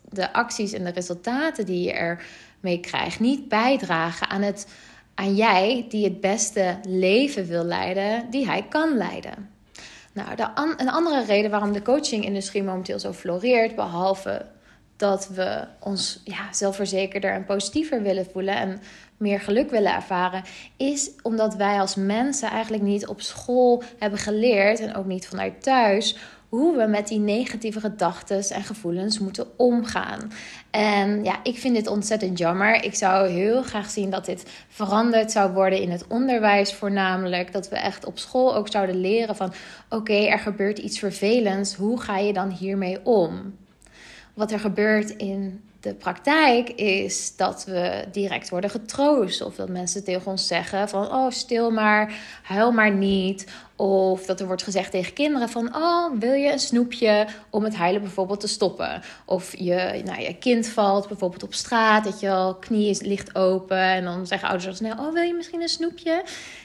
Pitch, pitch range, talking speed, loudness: 205 Hz, 190-225 Hz, 170 wpm, -23 LUFS